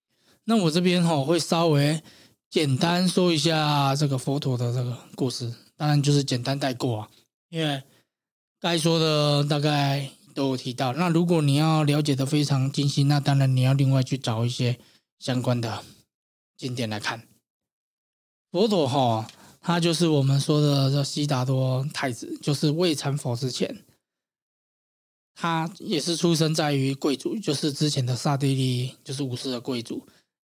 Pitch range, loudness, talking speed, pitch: 130-155 Hz, -24 LUFS, 235 characters per minute, 140 Hz